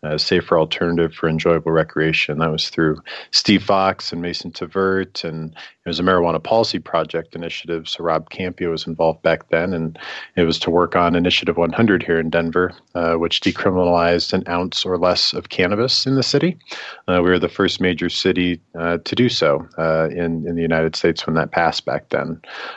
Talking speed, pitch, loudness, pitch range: 200 wpm, 85 Hz, -19 LUFS, 80-90 Hz